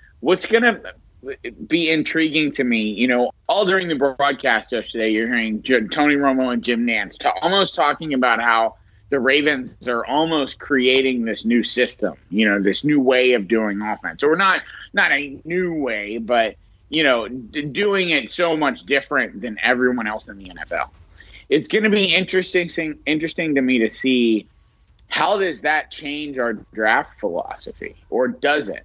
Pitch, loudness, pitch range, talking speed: 135 Hz, -19 LUFS, 115-160 Hz, 170 wpm